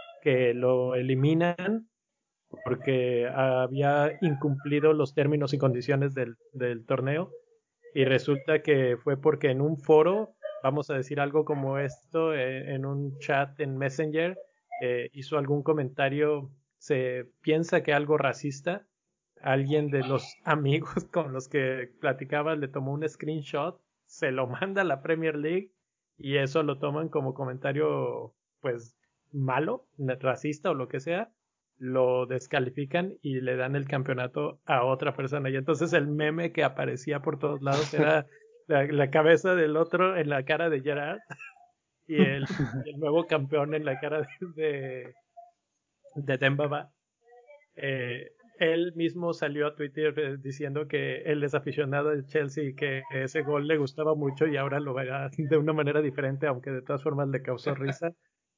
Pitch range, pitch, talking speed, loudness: 135-155 Hz, 145 Hz, 155 wpm, -28 LUFS